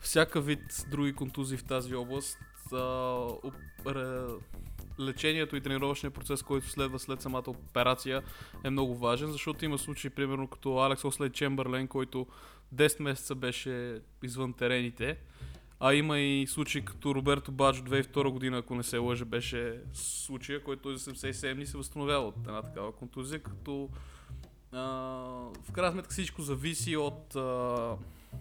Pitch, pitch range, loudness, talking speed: 130 Hz, 120-140 Hz, -33 LUFS, 145 wpm